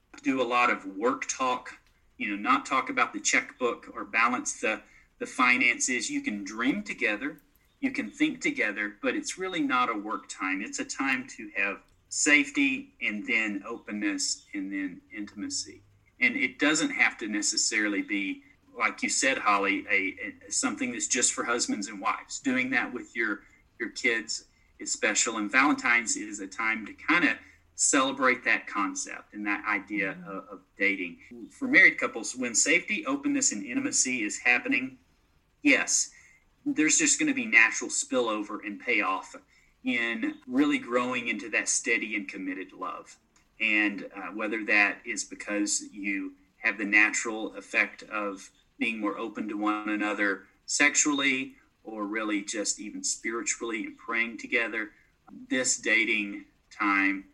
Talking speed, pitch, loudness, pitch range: 155 wpm, 275 Hz, -27 LUFS, 185-290 Hz